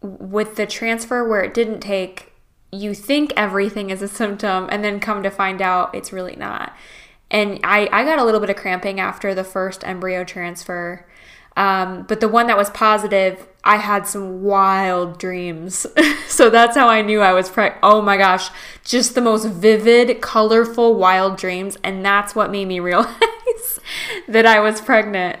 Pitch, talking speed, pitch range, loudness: 205 Hz, 180 wpm, 190-220 Hz, -17 LUFS